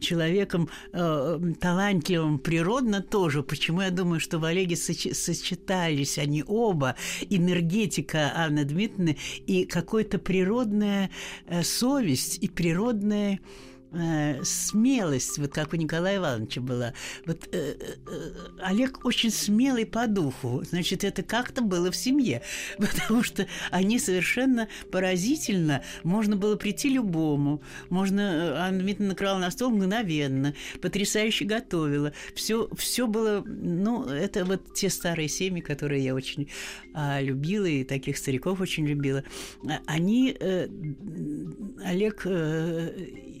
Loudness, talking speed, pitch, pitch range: -27 LUFS, 120 wpm, 180 Hz, 155-205 Hz